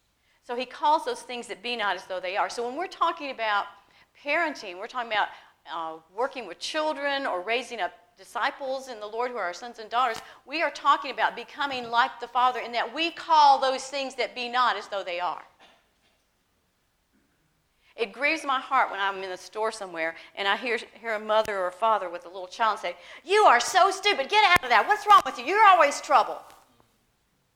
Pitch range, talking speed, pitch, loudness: 200-290 Hz, 215 wpm, 240 Hz, -25 LUFS